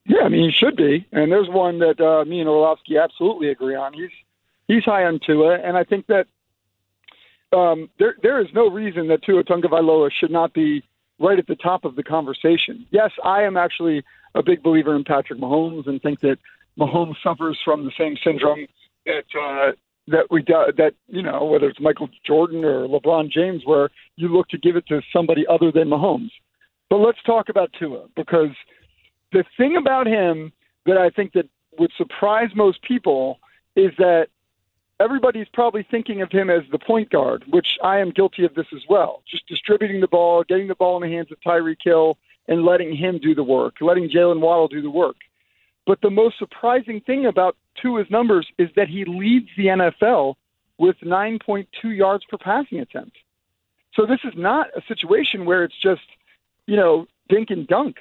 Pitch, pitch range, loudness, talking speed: 175 Hz, 155-205 Hz, -19 LUFS, 195 wpm